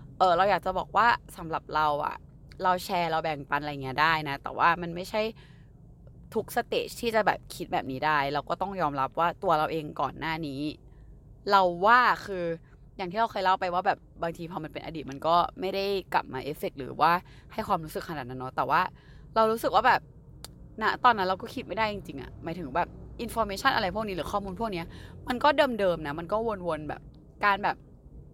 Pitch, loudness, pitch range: 170 Hz, -28 LUFS, 145-200 Hz